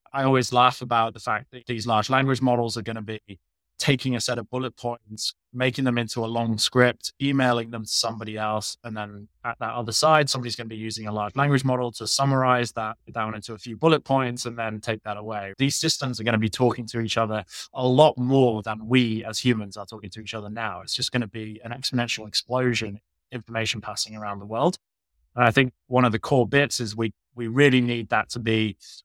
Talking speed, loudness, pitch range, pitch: 235 wpm, -24 LUFS, 110-125 Hz, 115 Hz